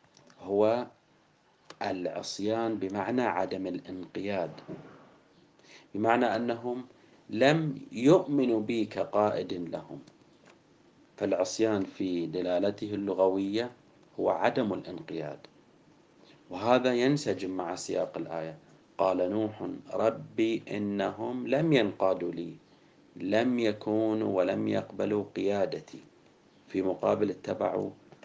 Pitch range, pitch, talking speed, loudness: 95-120 Hz, 110 Hz, 85 wpm, -30 LUFS